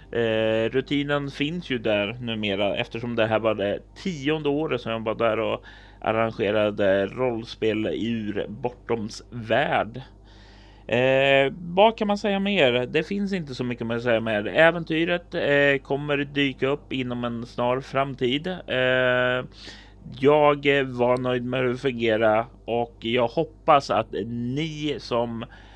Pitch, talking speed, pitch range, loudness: 125 Hz, 140 wpm, 110-140 Hz, -24 LUFS